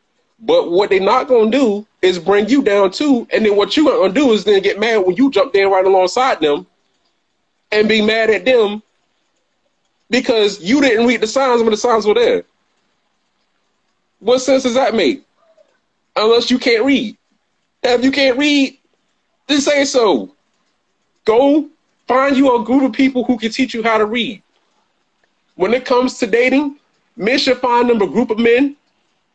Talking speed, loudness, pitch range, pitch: 180 wpm, -14 LUFS, 215-270 Hz, 245 Hz